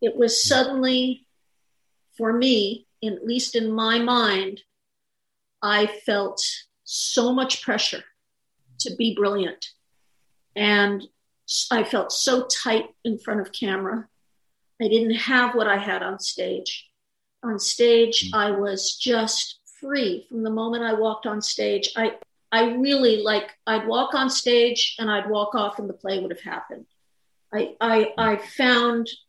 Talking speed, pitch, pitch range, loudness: 145 wpm, 225 Hz, 210-240 Hz, -22 LUFS